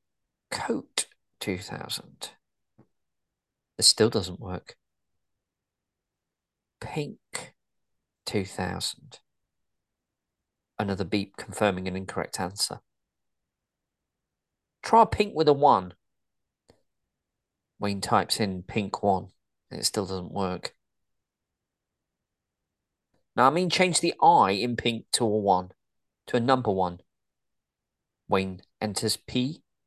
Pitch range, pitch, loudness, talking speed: 95-120 Hz, 105 Hz, -26 LUFS, 95 wpm